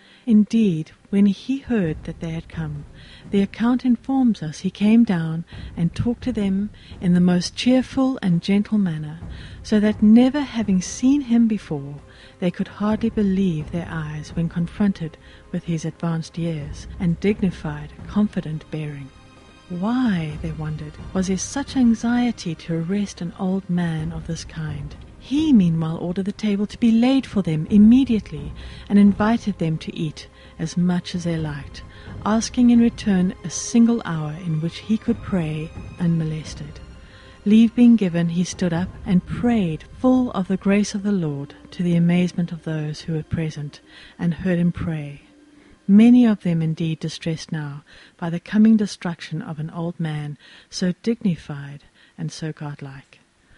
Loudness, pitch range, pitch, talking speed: -21 LUFS, 160-215 Hz, 180 Hz, 160 wpm